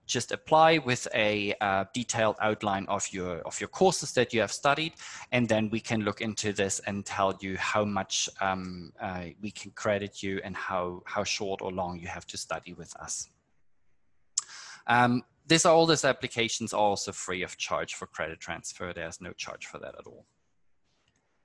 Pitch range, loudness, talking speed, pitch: 95-120 Hz, -29 LUFS, 185 wpm, 105 Hz